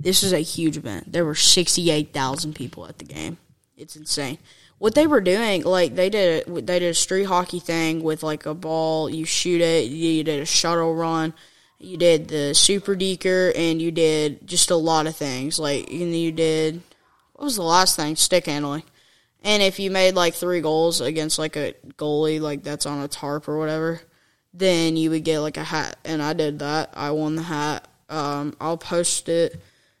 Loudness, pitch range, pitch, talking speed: -21 LUFS, 150-175 Hz, 160 Hz, 200 wpm